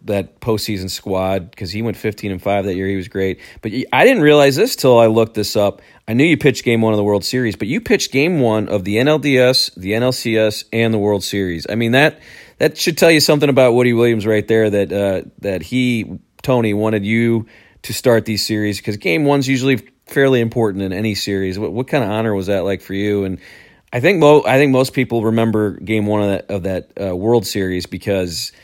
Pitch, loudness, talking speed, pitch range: 110 Hz, -16 LUFS, 230 wpm, 100-125 Hz